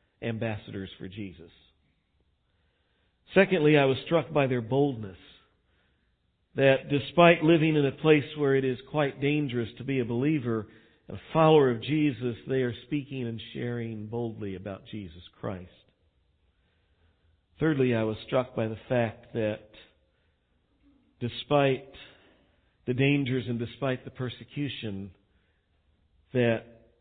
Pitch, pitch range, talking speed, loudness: 120 Hz, 95-135 Hz, 120 wpm, -27 LUFS